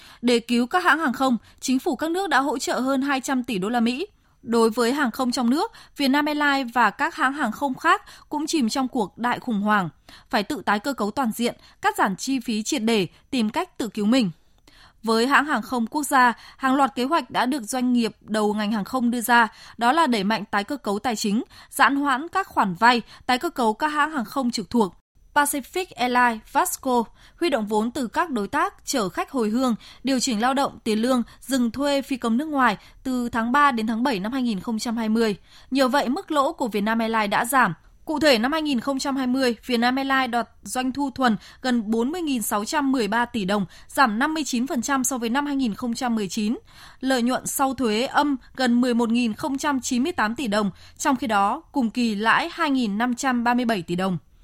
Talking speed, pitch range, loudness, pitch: 200 wpm, 225-275 Hz, -23 LUFS, 250 Hz